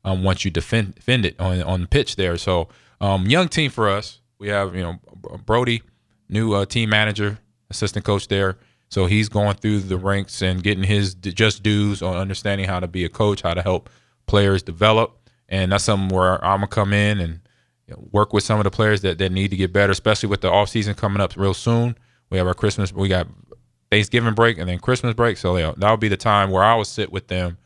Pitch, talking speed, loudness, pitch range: 100 Hz, 235 wpm, -20 LUFS, 95-105 Hz